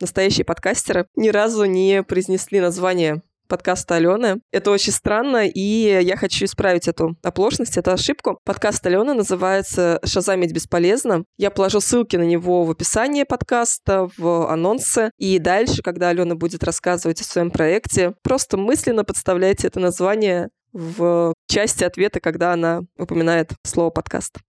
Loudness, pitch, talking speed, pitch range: -19 LUFS, 185 Hz, 140 wpm, 170-200 Hz